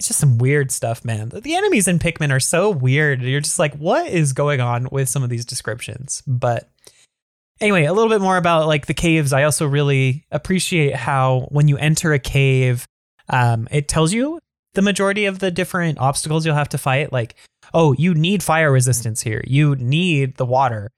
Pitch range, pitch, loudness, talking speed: 130-165 Hz, 145 Hz, -18 LUFS, 200 wpm